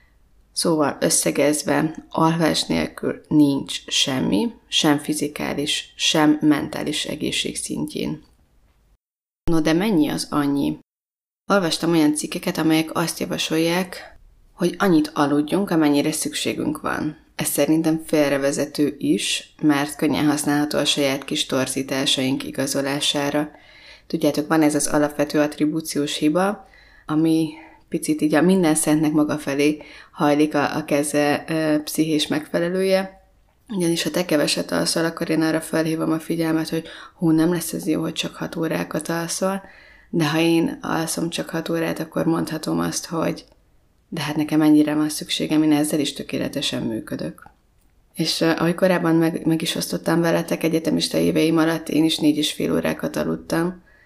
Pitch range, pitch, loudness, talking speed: 145-165 Hz, 155 Hz, -21 LUFS, 140 wpm